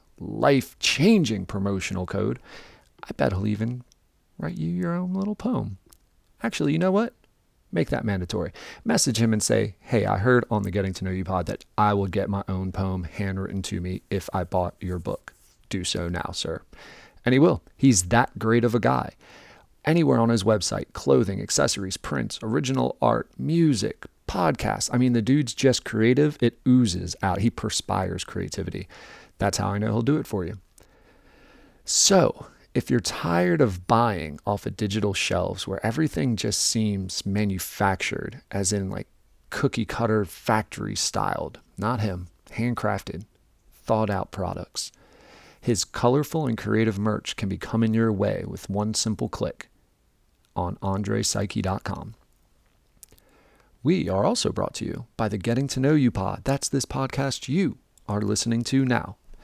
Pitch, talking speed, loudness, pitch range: 105 Hz, 160 wpm, -25 LUFS, 95-120 Hz